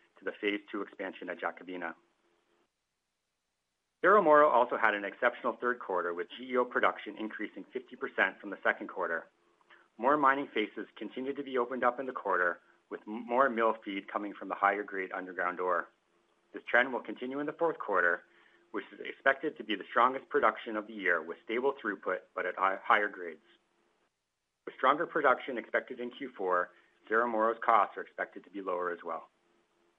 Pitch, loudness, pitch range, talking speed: 120 Hz, -31 LUFS, 100-140 Hz, 175 wpm